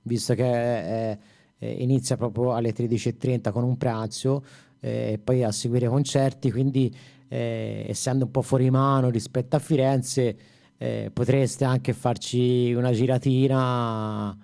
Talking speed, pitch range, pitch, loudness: 135 wpm, 120-130 Hz, 125 Hz, -25 LUFS